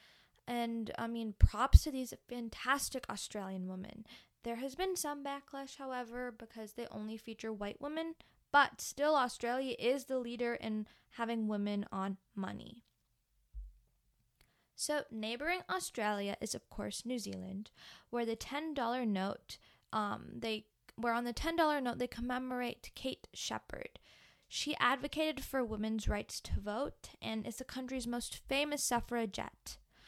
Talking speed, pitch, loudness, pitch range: 140 wpm, 240 Hz, -38 LUFS, 220-265 Hz